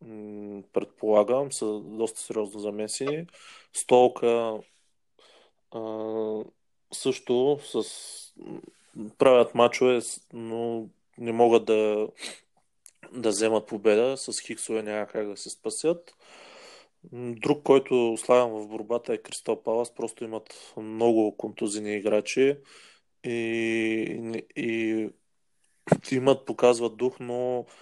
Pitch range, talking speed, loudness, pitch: 110-125 Hz, 95 wpm, -26 LUFS, 115 Hz